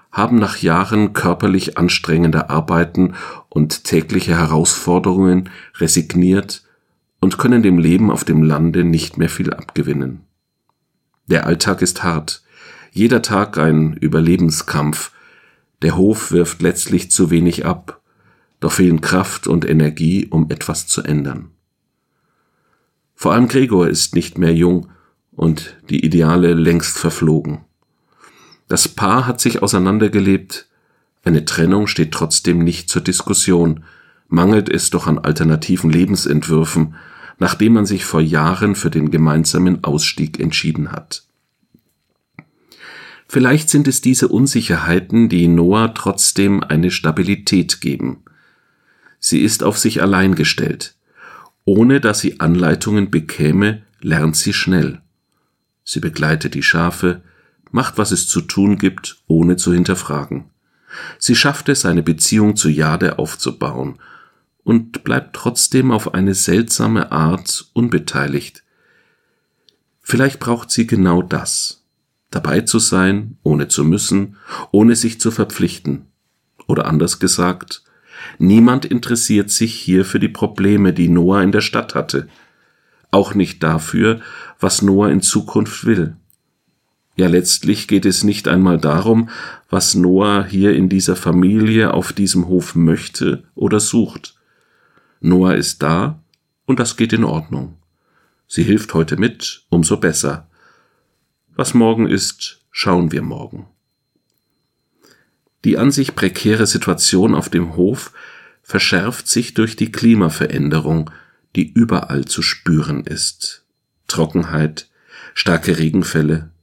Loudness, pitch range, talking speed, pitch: -15 LUFS, 80-105 Hz, 125 wpm, 90 Hz